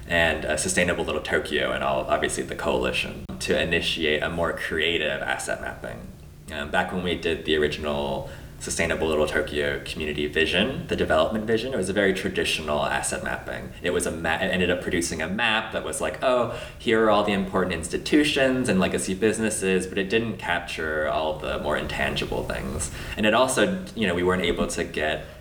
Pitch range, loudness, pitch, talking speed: 75-95 Hz, -24 LUFS, 85 Hz, 190 wpm